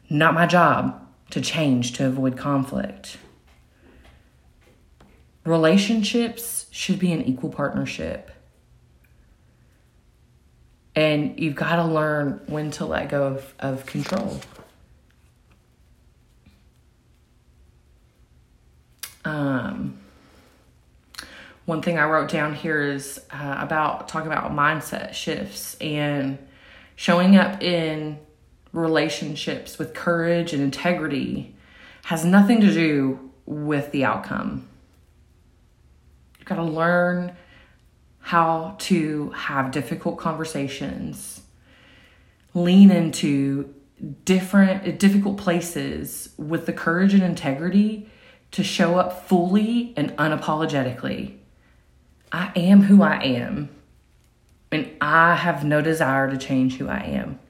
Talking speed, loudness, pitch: 100 wpm, -22 LUFS, 150 Hz